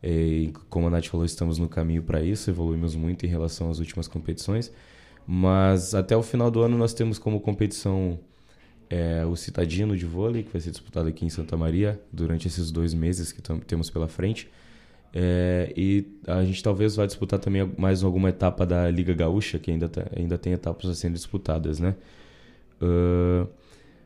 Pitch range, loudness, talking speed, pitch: 85-100 Hz, -26 LUFS, 185 wpm, 90 Hz